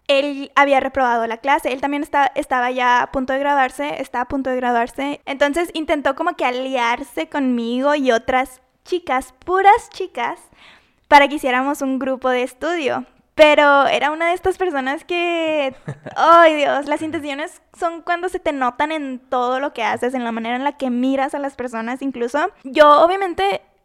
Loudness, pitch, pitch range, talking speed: -18 LUFS, 280 Hz, 255-315 Hz, 180 wpm